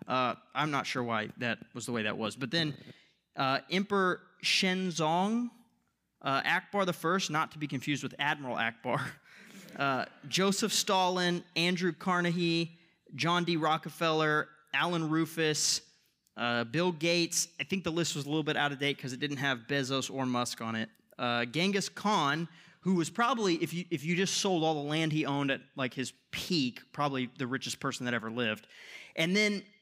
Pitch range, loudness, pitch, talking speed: 140-180 Hz, -31 LUFS, 160 Hz, 180 wpm